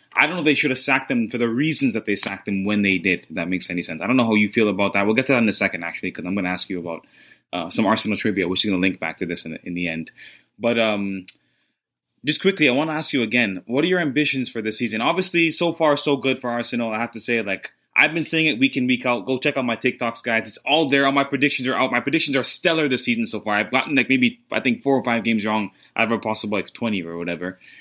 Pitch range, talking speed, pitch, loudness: 100-140 Hz, 305 wpm, 115 Hz, -20 LUFS